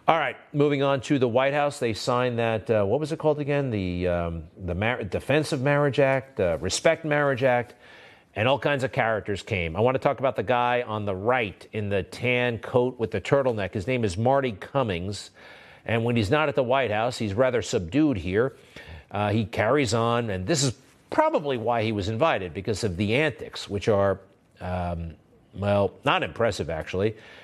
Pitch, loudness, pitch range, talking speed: 120 Hz, -25 LUFS, 105-140 Hz, 205 wpm